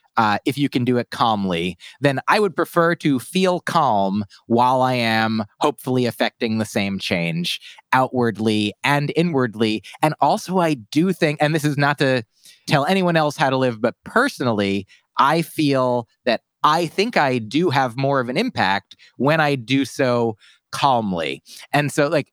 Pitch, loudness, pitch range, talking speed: 135 Hz, -20 LUFS, 115-150 Hz, 170 wpm